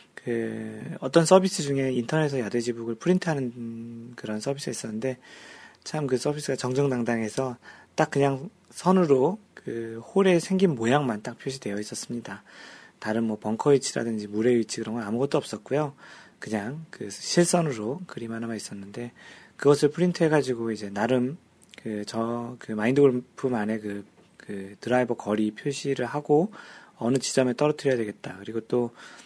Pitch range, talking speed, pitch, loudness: 115-145 Hz, 340 characters per minute, 125 Hz, -26 LUFS